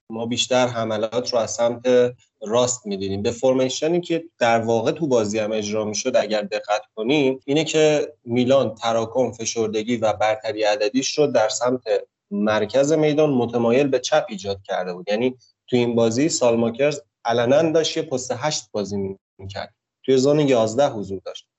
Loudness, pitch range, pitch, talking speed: -21 LUFS, 110-135 Hz, 120 Hz, 160 wpm